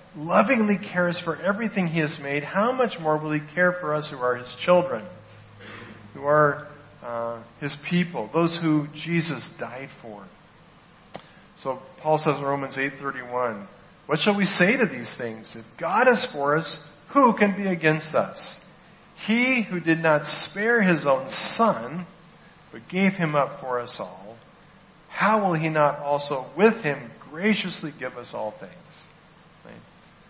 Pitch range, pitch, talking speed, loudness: 140-180 Hz, 155 Hz, 160 wpm, -24 LUFS